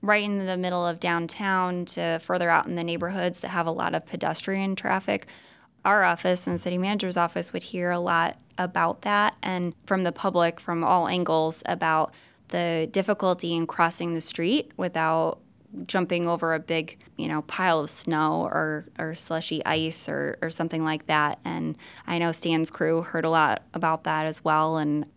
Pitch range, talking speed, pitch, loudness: 160-180 Hz, 185 wpm, 170 Hz, -26 LUFS